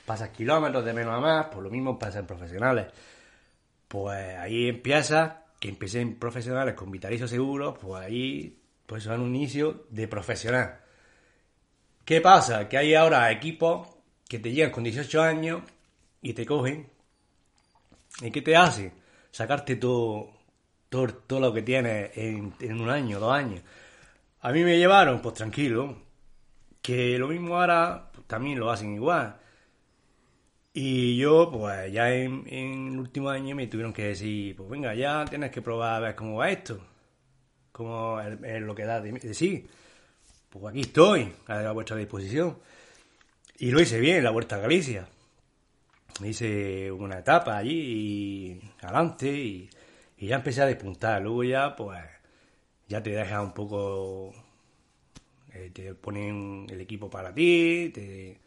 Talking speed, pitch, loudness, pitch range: 155 wpm, 120 Hz, -26 LUFS, 105-140 Hz